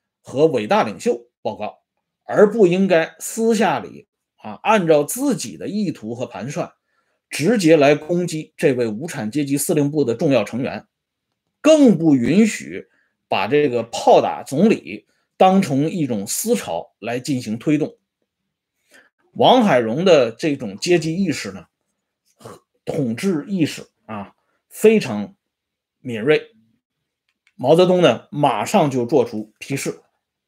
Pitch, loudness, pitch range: 155 Hz, -18 LUFS, 130-200 Hz